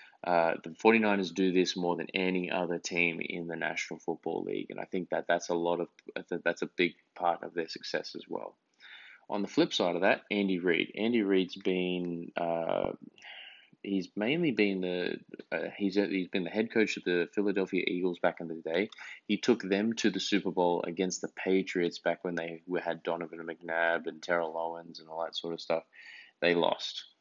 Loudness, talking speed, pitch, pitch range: -32 LUFS, 205 wpm, 90 Hz, 85-95 Hz